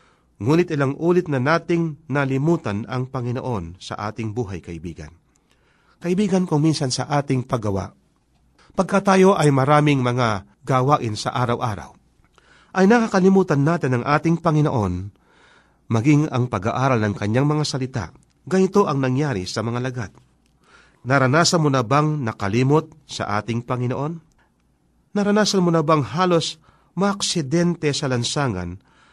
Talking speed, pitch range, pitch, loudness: 125 wpm, 120-165 Hz, 135 Hz, -20 LUFS